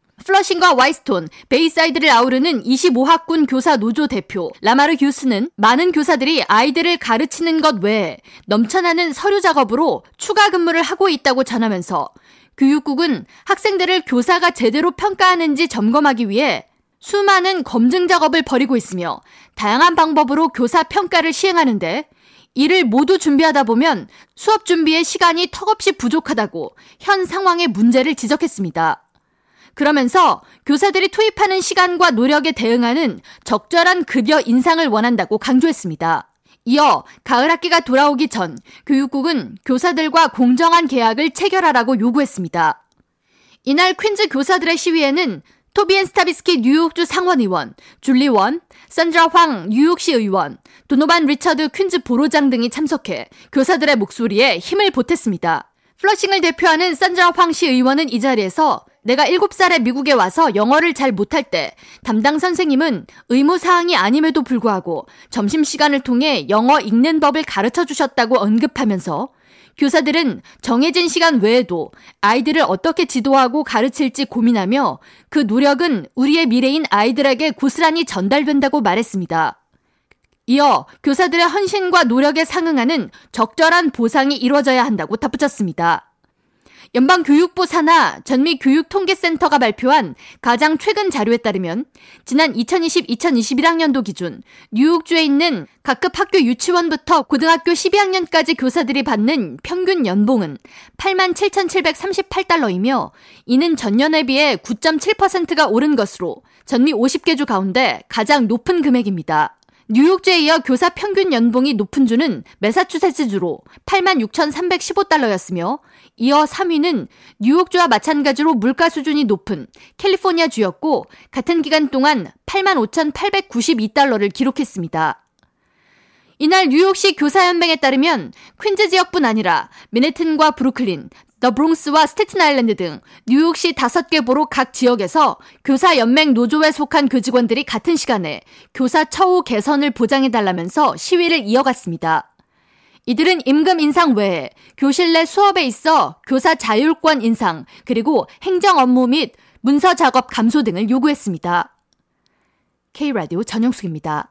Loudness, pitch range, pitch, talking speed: -15 LUFS, 245-340 Hz, 295 Hz, 320 characters per minute